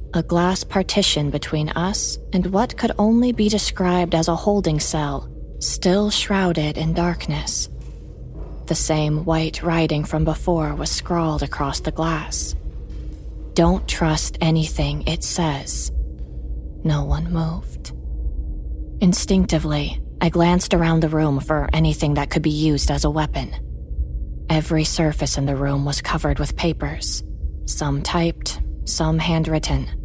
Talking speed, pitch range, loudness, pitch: 130 wpm, 135-170 Hz, -20 LUFS, 155 Hz